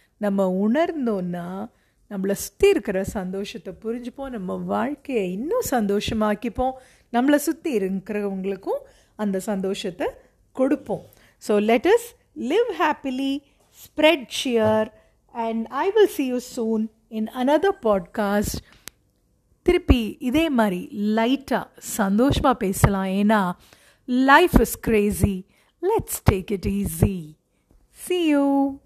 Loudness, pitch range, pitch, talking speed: -23 LUFS, 200-280 Hz, 225 Hz, 100 wpm